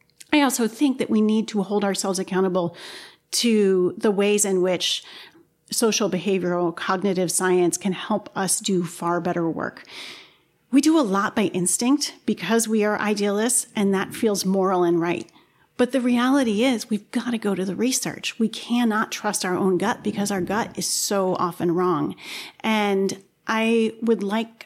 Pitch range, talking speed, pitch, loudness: 185-230 Hz, 170 wpm, 205 Hz, -22 LUFS